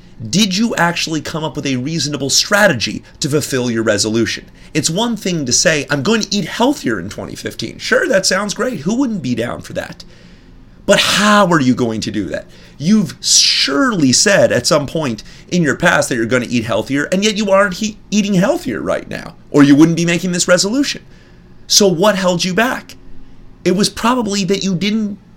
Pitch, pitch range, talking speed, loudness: 180 Hz, 145-210 Hz, 200 wpm, -14 LUFS